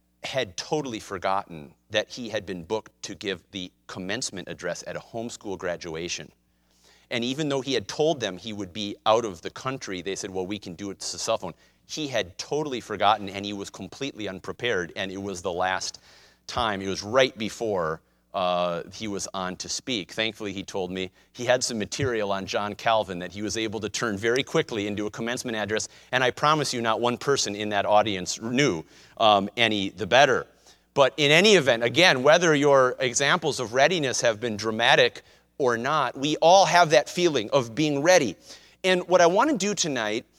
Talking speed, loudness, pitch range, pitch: 200 wpm, -24 LUFS, 95-130 Hz, 105 Hz